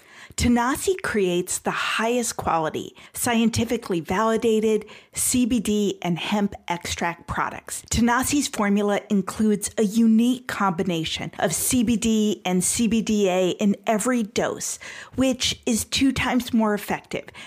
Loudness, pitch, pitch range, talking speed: -23 LUFS, 220 Hz, 200-240 Hz, 105 wpm